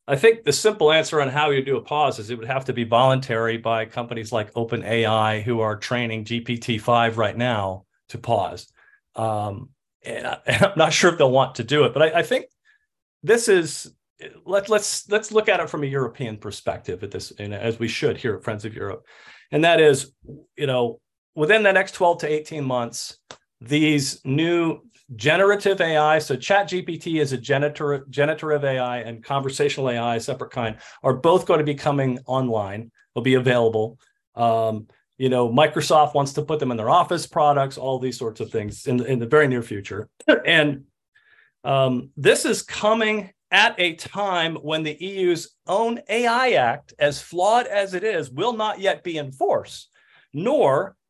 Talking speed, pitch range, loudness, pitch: 190 wpm, 120-170 Hz, -21 LUFS, 140 Hz